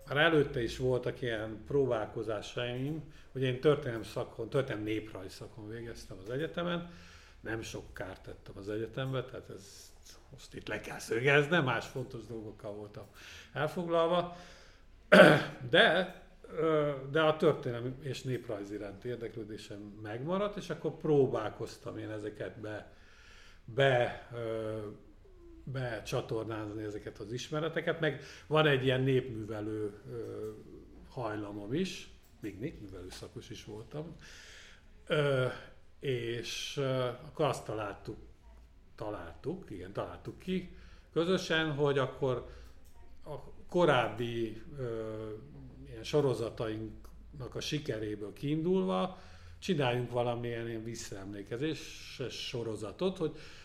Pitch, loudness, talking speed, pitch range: 120 Hz, -33 LUFS, 100 wpm, 110-145 Hz